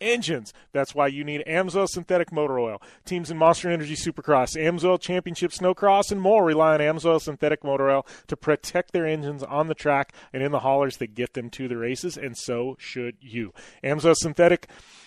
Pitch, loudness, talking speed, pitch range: 150 Hz, -24 LUFS, 190 wpm, 135-175 Hz